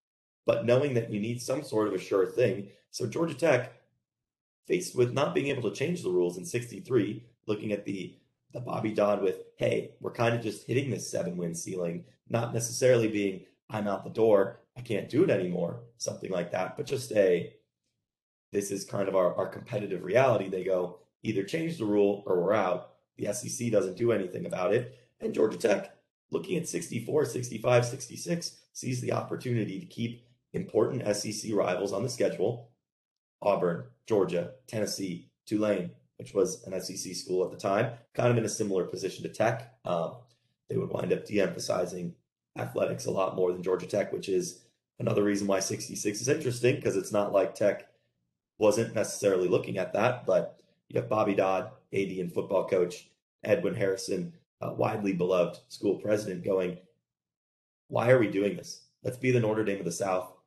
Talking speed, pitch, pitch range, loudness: 185 wpm, 105 Hz, 95-125 Hz, -30 LUFS